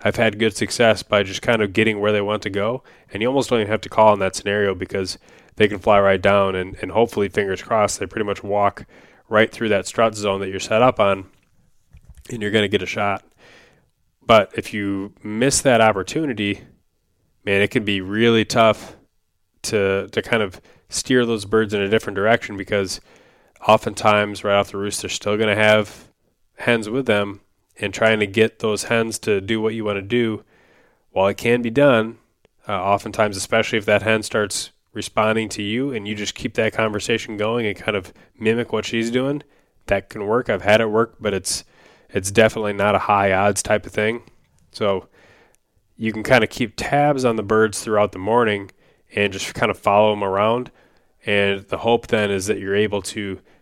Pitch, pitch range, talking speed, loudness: 105 Hz, 100-110 Hz, 205 wpm, -20 LUFS